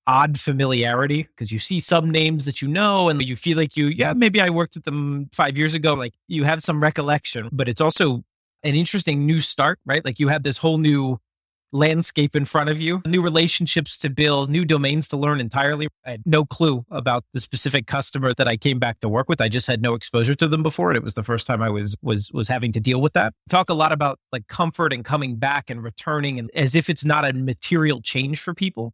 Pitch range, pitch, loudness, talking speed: 125-160 Hz, 145 Hz, -20 LUFS, 240 wpm